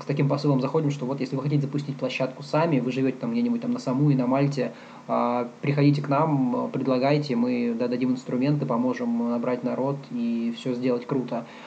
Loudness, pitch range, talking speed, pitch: -25 LUFS, 125-145 Hz, 185 wpm, 130 Hz